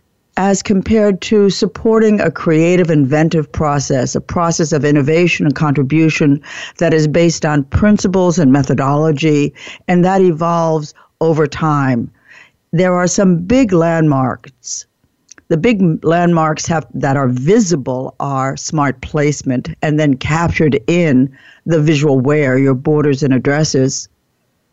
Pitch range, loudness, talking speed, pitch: 145-175 Hz, -13 LUFS, 125 wpm, 155 Hz